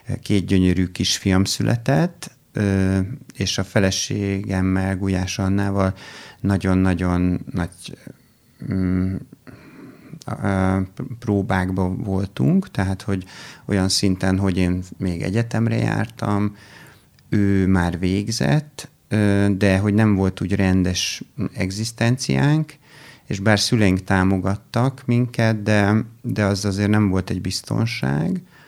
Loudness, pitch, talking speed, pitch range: -21 LUFS, 100 Hz, 95 wpm, 95-115 Hz